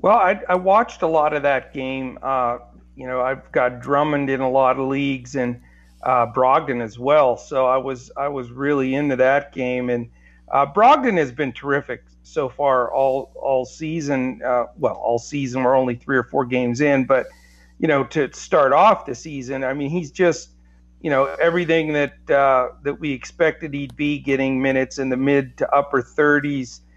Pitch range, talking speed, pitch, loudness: 125-145 Hz, 190 wpm, 135 Hz, -20 LUFS